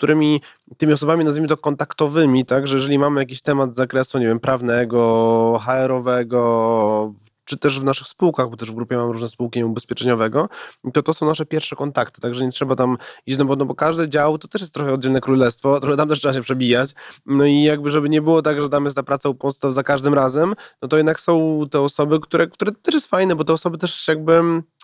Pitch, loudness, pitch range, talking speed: 140 Hz, -18 LUFS, 130-155 Hz, 215 wpm